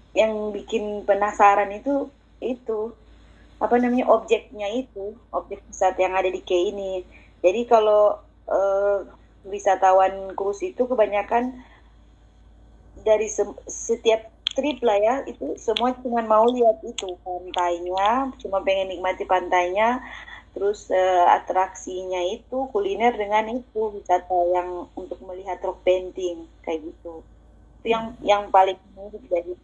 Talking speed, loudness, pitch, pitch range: 120 wpm, -23 LUFS, 200 Hz, 185-225 Hz